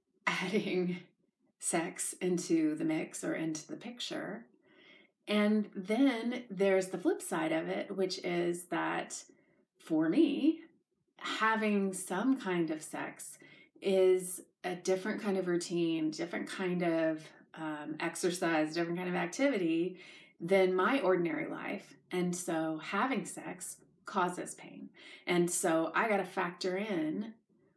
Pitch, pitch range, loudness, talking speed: 185 Hz, 175-215 Hz, -33 LUFS, 130 wpm